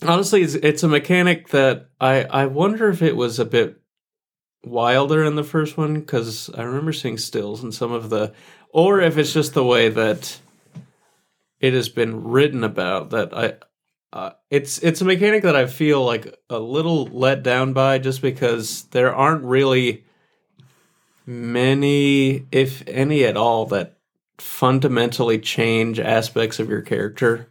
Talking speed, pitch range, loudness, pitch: 155 wpm, 120-150 Hz, -19 LUFS, 135 Hz